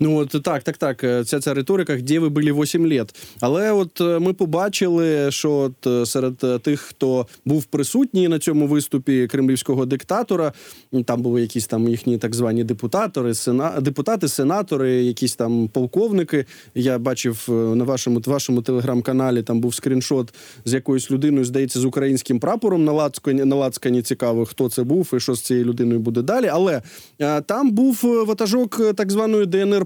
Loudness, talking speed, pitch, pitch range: -20 LUFS, 165 wpm, 135 Hz, 125-160 Hz